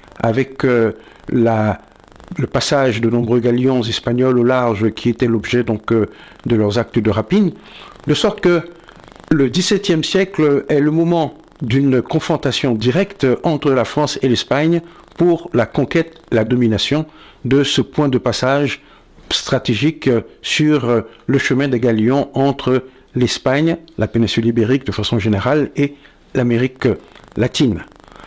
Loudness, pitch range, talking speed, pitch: -16 LUFS, 120-150 Hz, 140 wpm, 130 Hz